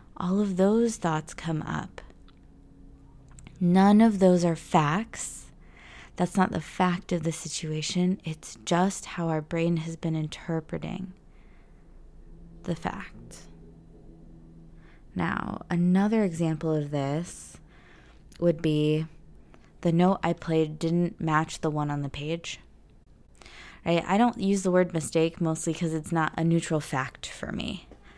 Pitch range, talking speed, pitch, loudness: 155-180 Hz, 130 wpm, 165 Hz, -27 LUFS